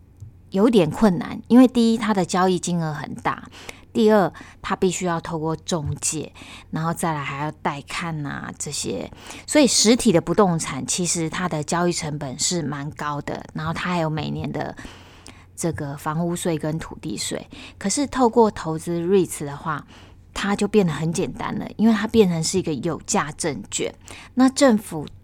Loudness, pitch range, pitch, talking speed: -22 LUFS, 150-205 Hz, 170 Hz, 265 characters per minute